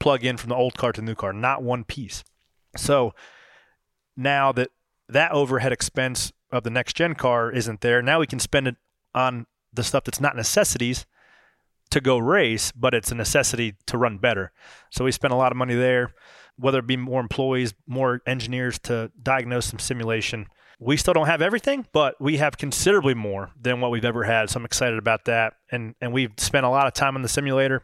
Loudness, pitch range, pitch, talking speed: -23 LUFS, 115-135 Hz, 125 Hz, 210 wpm